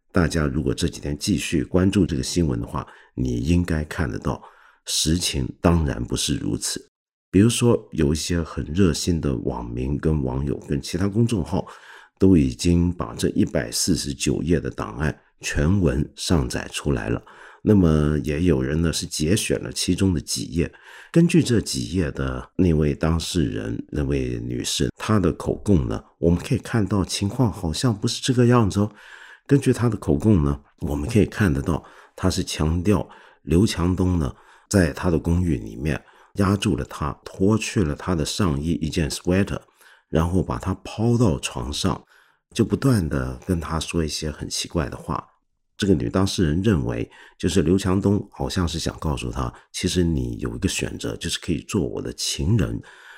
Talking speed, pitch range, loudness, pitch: 265 characters per minute, 75-100 Hz, -23 LUFS, 85 Hz